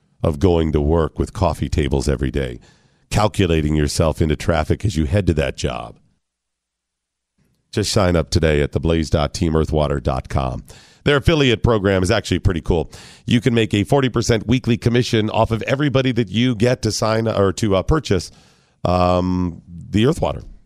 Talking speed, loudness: 160 wpm, -19 LUFS